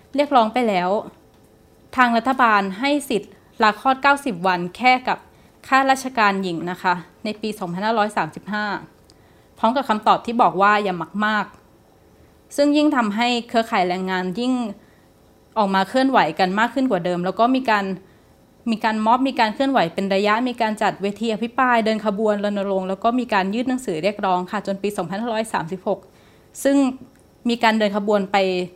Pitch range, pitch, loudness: 195-240 Hz, 215 Hz, -20 LUFS